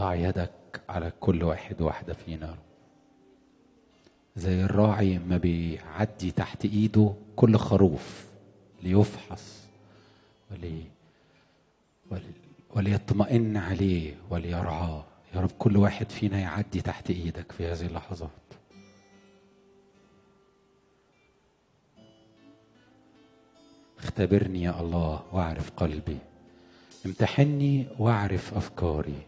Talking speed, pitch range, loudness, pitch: 80 wpm, 85-105 Hz, -28 LUFS, 95 Hz